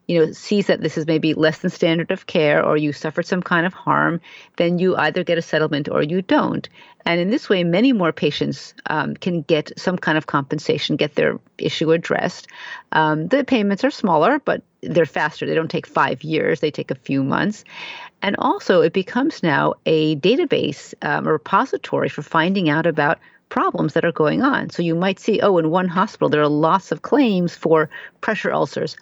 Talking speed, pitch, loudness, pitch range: 205 wpm, 170 Hz, -19 LUFS, 155-190 Hz